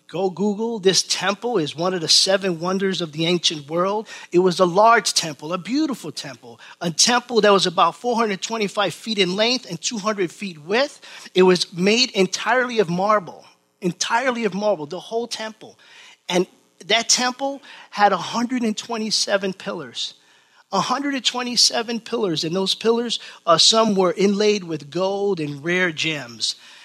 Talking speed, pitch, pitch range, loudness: 150 wpm, 200 Hz, 180-230 Hz, -20 LUFS